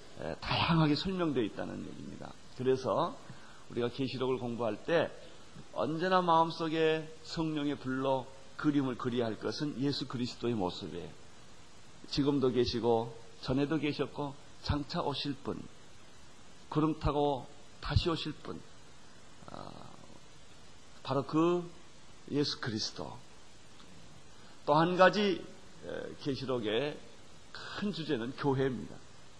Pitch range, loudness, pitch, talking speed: 125-160 Hz, -33 LUFS, 145 Hz, 235 characters per minute